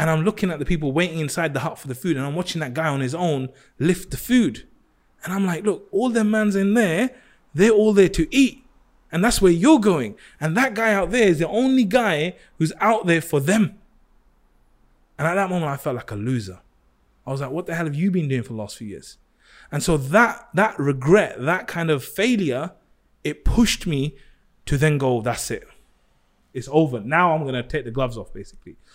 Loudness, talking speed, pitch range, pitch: -21 LUFS, 225 wpm, 140-205 Hz, 165 Hz